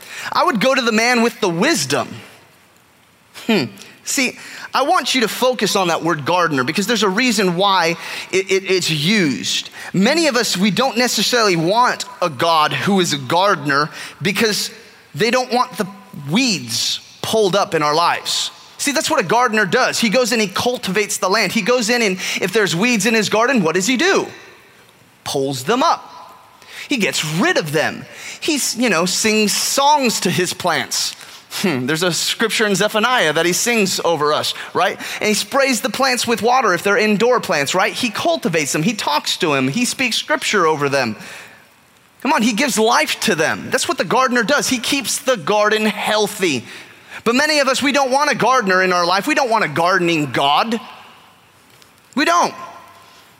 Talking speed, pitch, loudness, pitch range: 190 wpm, 215 Hz, -16 LUFS, 185-250 Hz